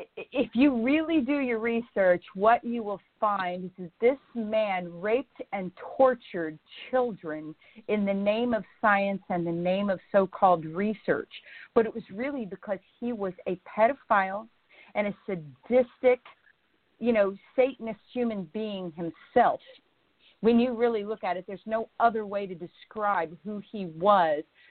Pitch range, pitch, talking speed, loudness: 190-240 Hz, 210 Hz, 150 wpm, -28 LUFS